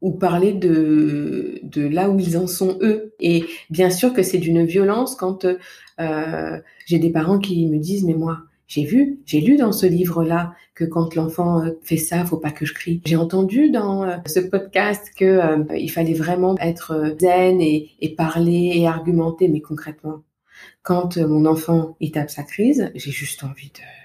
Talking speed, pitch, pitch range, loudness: 185 wpm, 170 Hz, 160-185 Hz, -19 LUFS